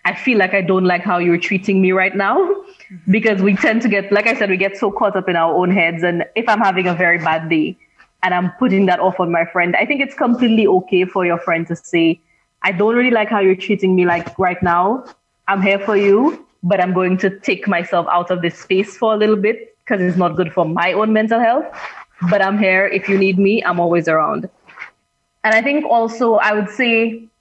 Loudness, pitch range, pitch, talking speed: -16 LUFS, 180-215 Hz, 195 Hz, 240 wpm